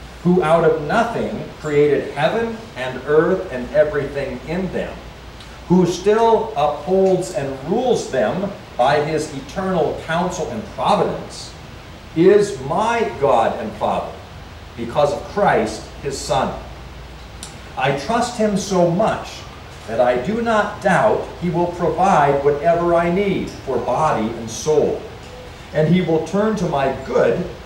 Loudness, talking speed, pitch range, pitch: -19 LUFS, 130 wpm, 145-195 Hz, 170 Hz